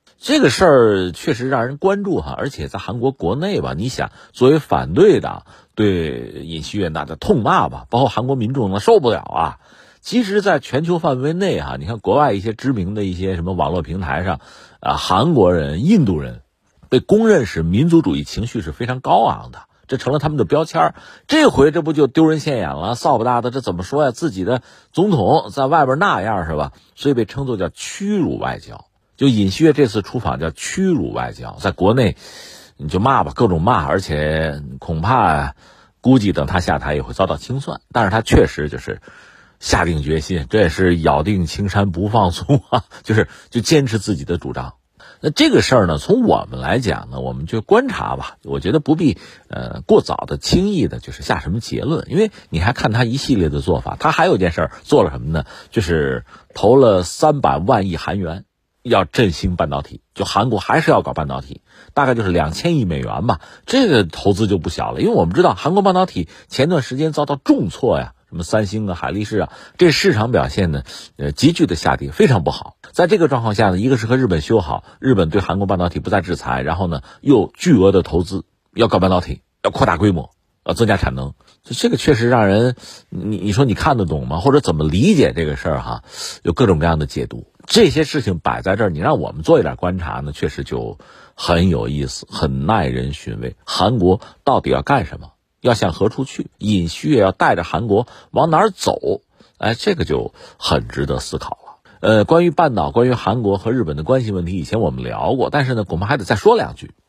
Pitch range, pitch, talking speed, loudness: 80-135 Hz, 100 Hz, 310 characters per minute, -17 LUFS